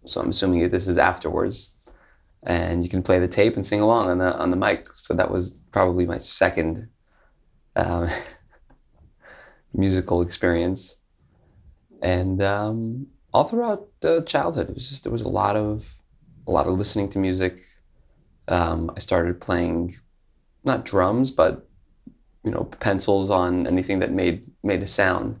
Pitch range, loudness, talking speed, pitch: 85-105 Hz, -23 LUFS, 160 wpm, 90 Hz